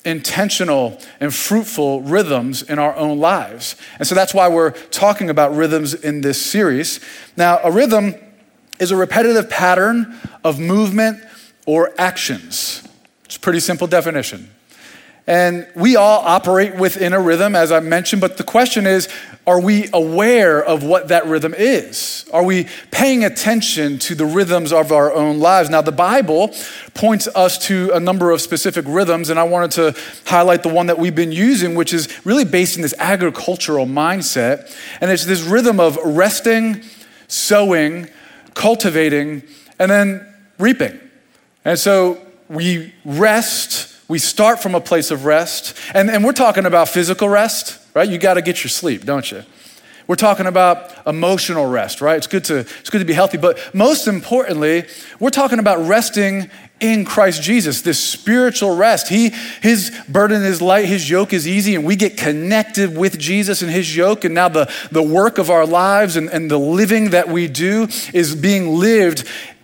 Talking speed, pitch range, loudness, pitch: 170 wpm, 165-210 Hz, -15 LUFS, 185 Hz